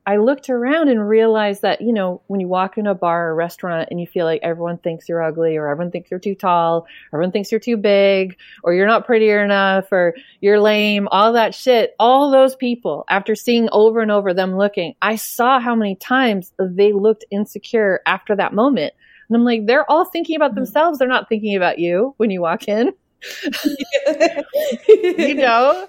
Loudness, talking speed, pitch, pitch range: -17 LUFS, 200 wpm, 215 Hz, 185-255 Hz